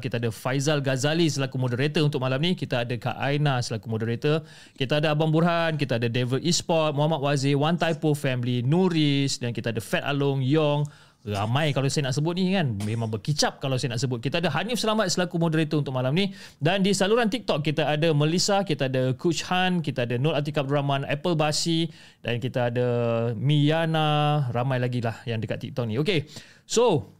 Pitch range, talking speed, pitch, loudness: 125-160 Hz, 195 wpm, 145 Hz, -25 LUFS